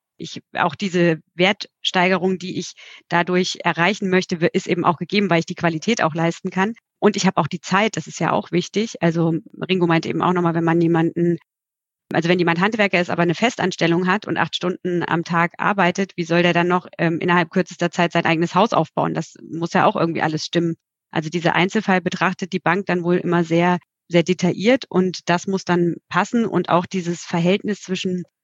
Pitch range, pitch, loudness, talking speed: 170-185 Hz, 175 Hz, -20 LUFS, 205 wpm